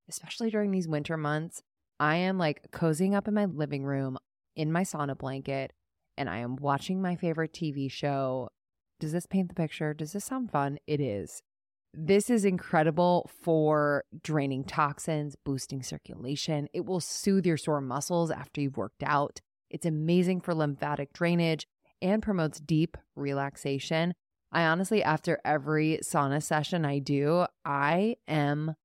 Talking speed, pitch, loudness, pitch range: 155 wpm, 155 Hz, -30 LUFS, 145-175 Hz